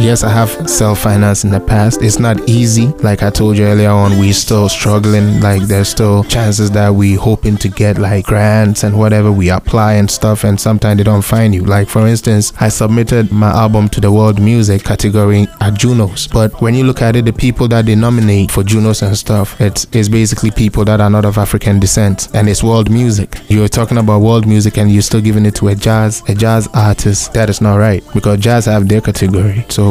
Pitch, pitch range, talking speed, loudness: 105 Hz, 105-110 Hz, 225 wpm, -10 LUFS